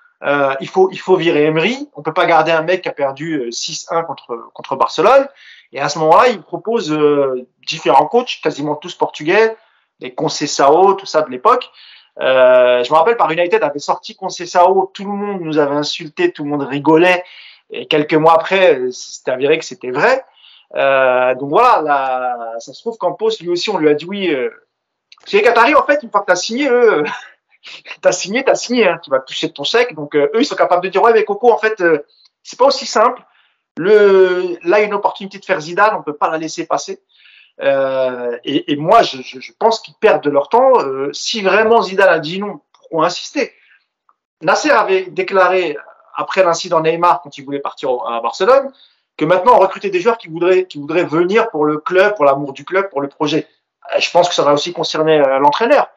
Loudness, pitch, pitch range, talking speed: -14 LUFS, 175 Hz, 150-215 Hz, 220 wpm